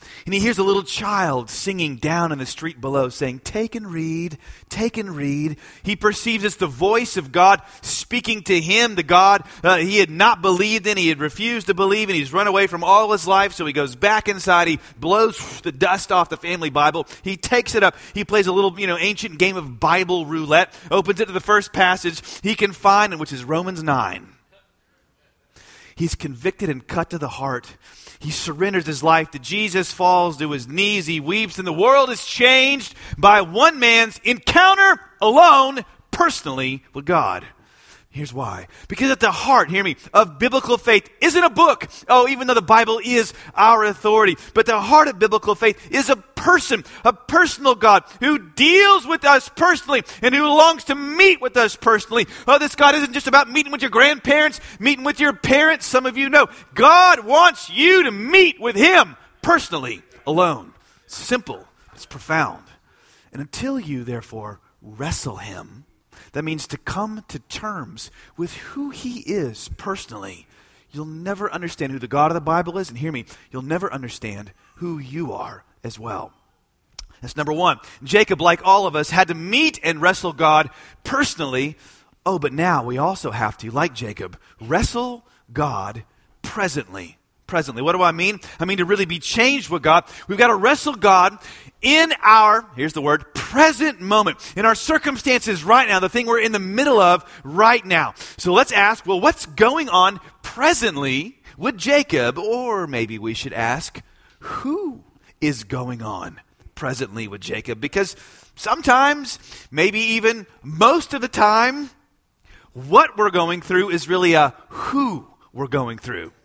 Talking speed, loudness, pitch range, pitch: 180 wpm, -17 LUFS, 155-240 Hz, 195 Hz